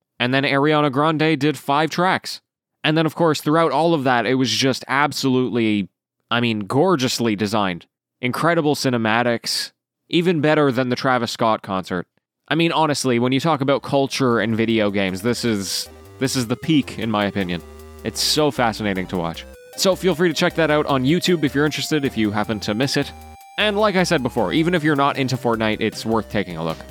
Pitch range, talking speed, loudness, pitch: 110-155 Hz, 205 wpm, -19 LUFS, 130 Hz